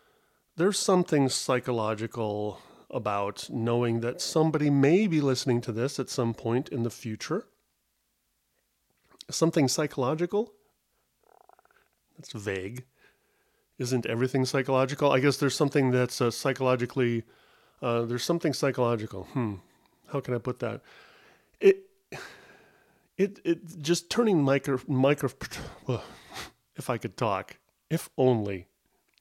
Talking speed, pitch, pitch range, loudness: 115 wpm, 135 Hz, 120-160 Hz, -28 LUFS